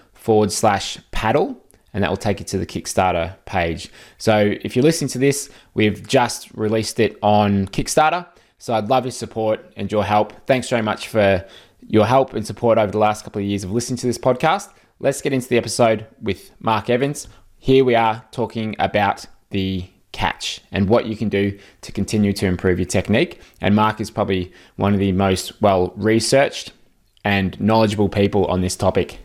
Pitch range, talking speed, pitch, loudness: 100-115 Hz, 190 wpm, 105 Hz, -19 LUFS